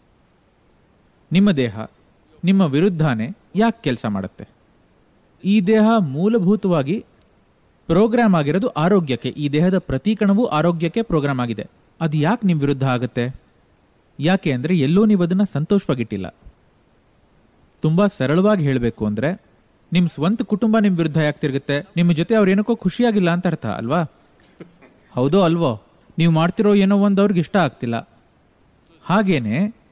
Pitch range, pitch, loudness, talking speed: 140-200 Hz, 170 Hz, -19 LUFS, 115 wpm